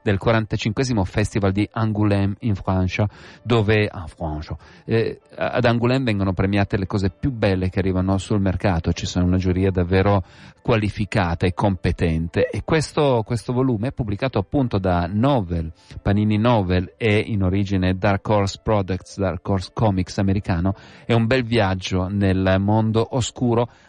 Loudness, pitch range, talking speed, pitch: -21 LUFS, 95-115 Hz, 150 wpm, 105 Hz